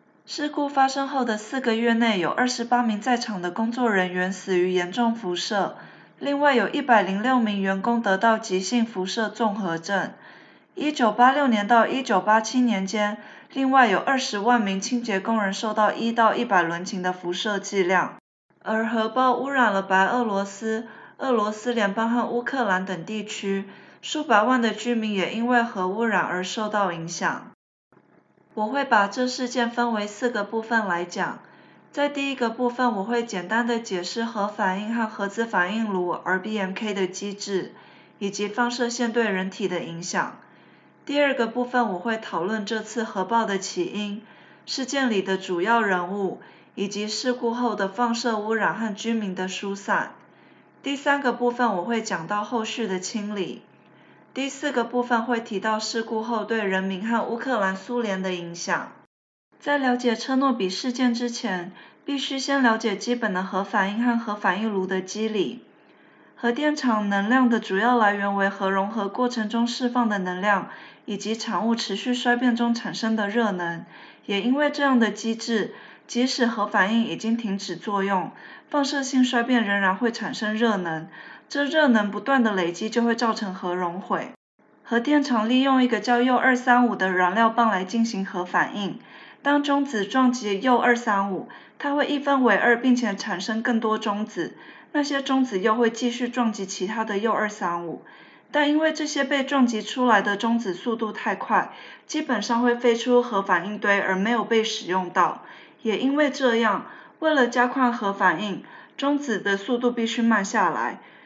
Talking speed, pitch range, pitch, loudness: 260 characters per minute, 200-245 Hz, 225 Hz, -24 LUFS